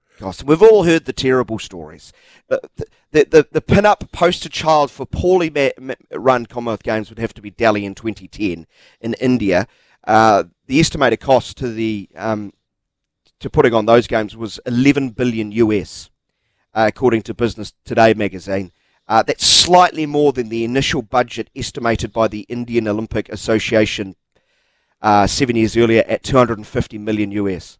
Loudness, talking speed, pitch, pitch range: -16 LUFS, 155 wpm, 115 Hz, 105-130 Hz